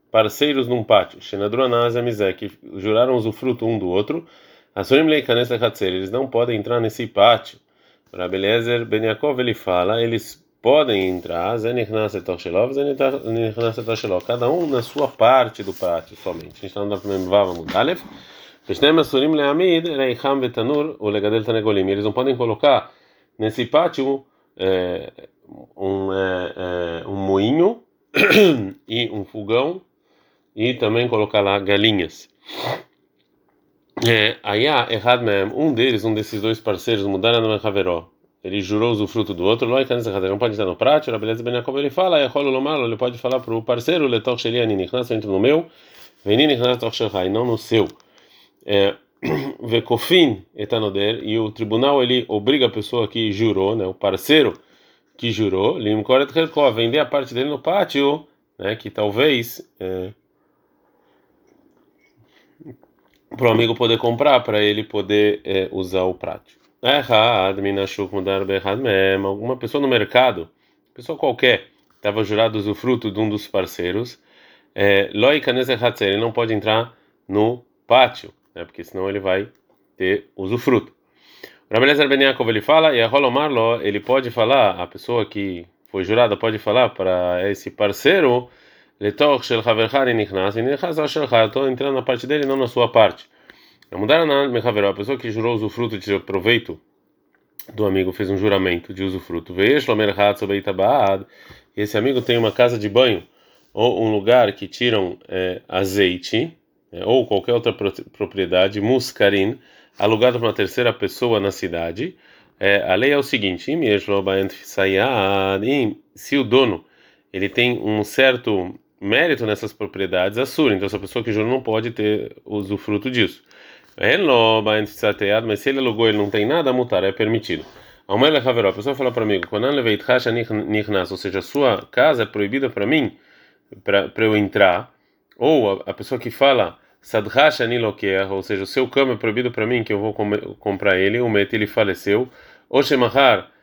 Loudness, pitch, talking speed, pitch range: -19 LUFS, 110 Hz, 140 wpm, 100-125 Hz